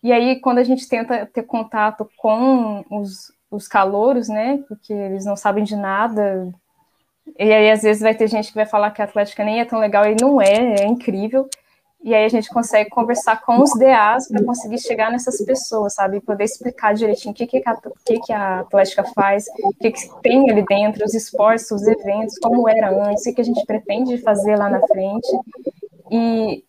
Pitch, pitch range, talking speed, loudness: 215 Hz, 205-235 Hz, 210 wpm, -17 LUFS